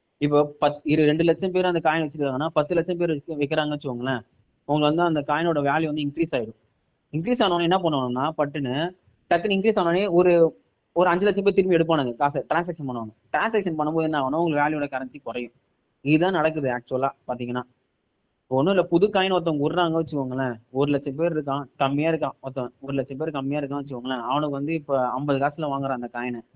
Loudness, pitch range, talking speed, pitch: -24 LUFS, 135-165 Hz, 180 wpm, 150 Hz